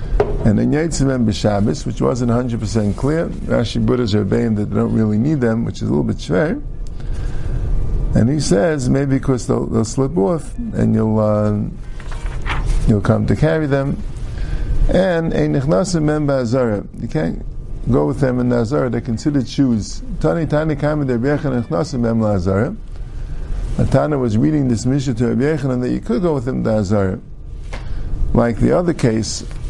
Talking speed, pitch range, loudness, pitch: 145 wpm, 110-140 Hz, -18 LUFS, 120 Hz